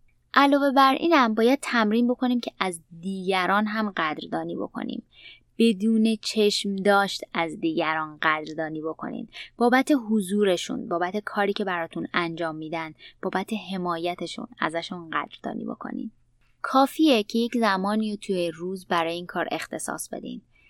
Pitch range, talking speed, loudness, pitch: 170-235 Hz, 130 wpm, -25 LUFS, 200 Hz